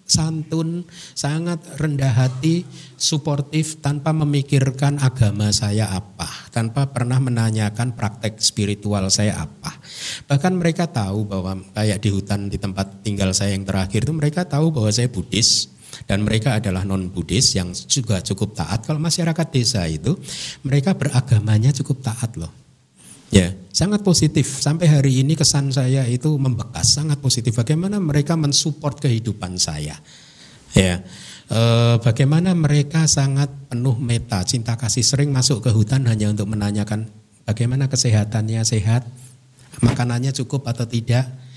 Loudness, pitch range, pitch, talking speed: -19 LUFS, 105-145 Hz, 125 Hz, 135 wpm